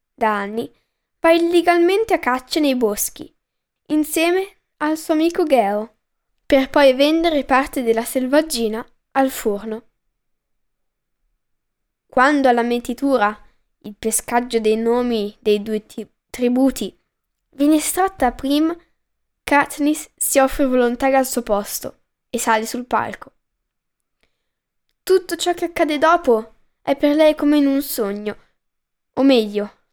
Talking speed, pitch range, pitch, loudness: 120 wpm, 225-305 Hz, 265 Hz, -18 LUFS